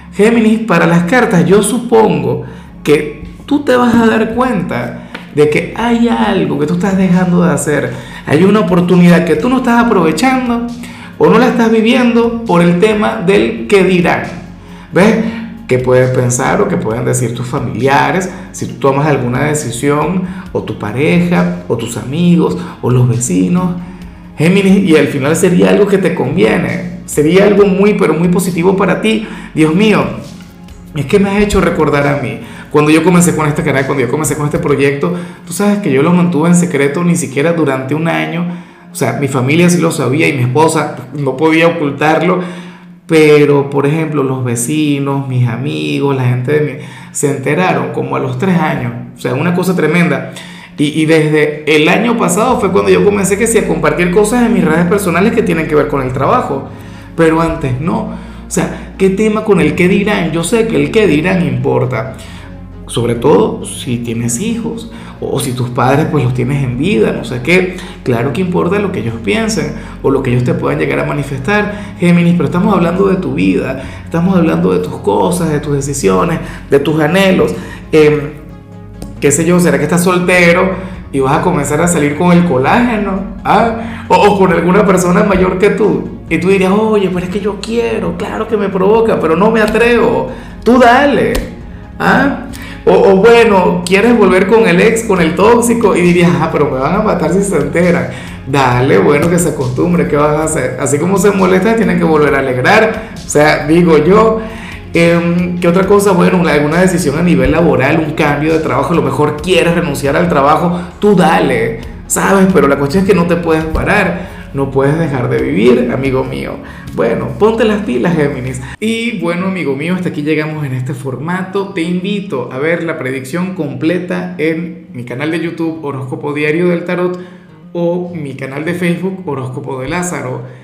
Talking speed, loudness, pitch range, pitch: 190 wpm, -11 LUFS, 145-195 Hz, 170 Hz